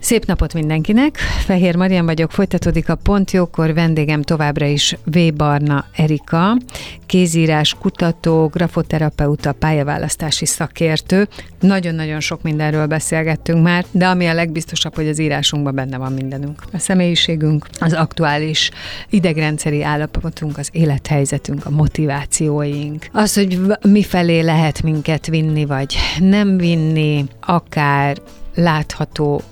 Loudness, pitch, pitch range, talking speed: -16 LUFS, 160 Hz, 150-175 Hz, 115 wpm